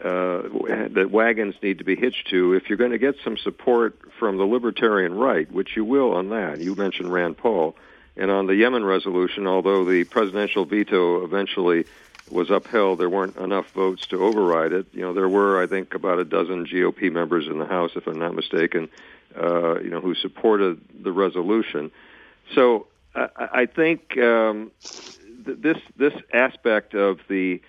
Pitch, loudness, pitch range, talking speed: 95 Hz, -22 LUFS, 90-110 Hz, 180 wpm